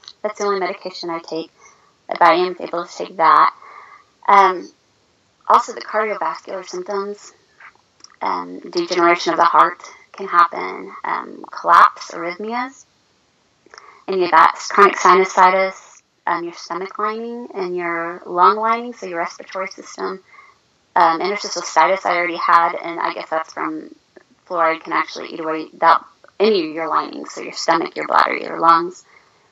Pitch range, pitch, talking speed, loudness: 170-215 Hz, 185 Hz, 150 wpm, -17 LUFS